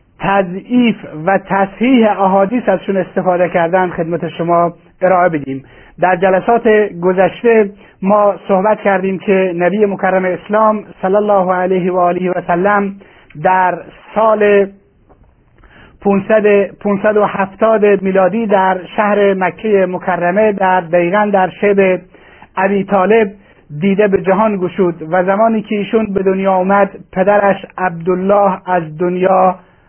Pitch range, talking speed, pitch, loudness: 180-205 Hz, 115 wpm, 190 Hz, -13 LUFS